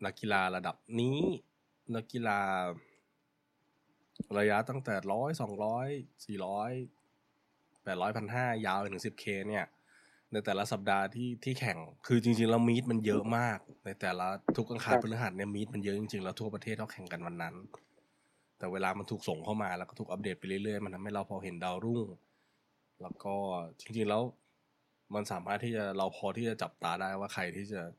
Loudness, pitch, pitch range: -35 LUFS, 105 Hz, 95-115 Hz